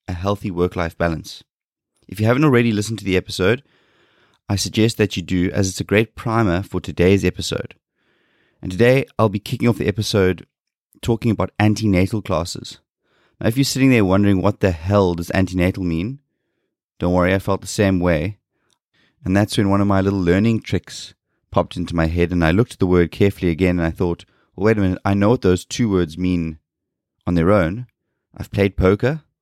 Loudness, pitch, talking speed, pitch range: -19 LUFS, 95 Hz, 200 wpm, 90-110 Hz